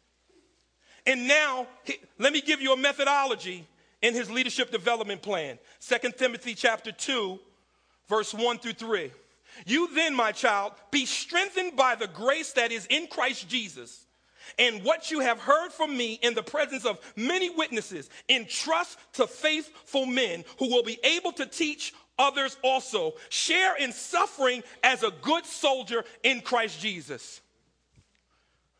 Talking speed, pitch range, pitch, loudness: 145 wpm, 230-300 Hz, 255 Hz, -27 LUFS